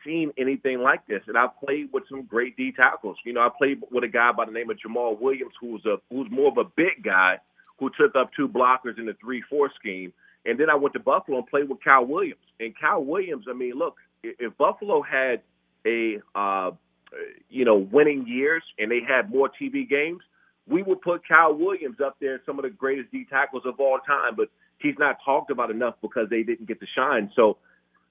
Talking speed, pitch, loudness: 220 wpm, 135 Hz, -24 LUFS